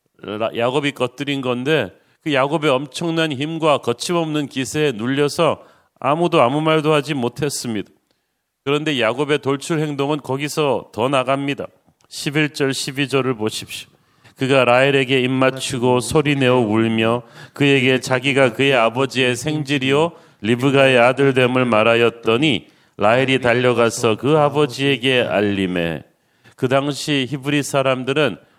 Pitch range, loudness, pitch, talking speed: 125-150 Hz, -18 LUFS, 135 Hz, 290 characters per minute